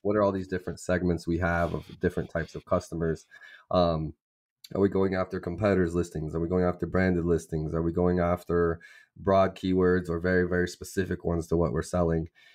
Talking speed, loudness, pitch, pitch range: 195 wpm, -28 LUFS, 90 Hz, 85-90 Hz